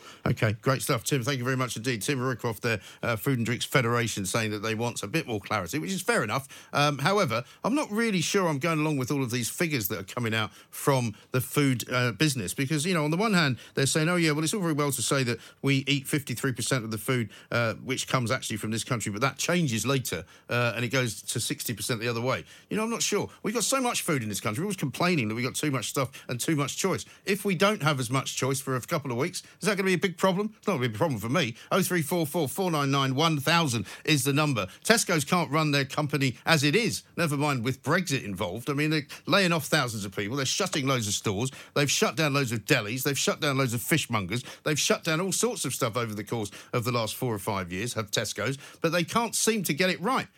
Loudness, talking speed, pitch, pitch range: -27 LUFS, 265 wpm, 140 Hz, 120-165 Hz